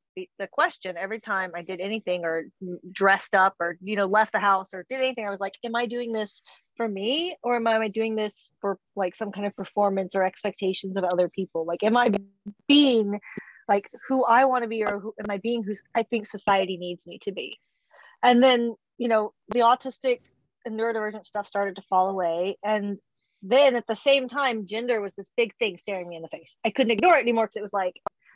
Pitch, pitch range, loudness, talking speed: 205 Hz, 190-235 Hz, -25 LUFS, 225 wpm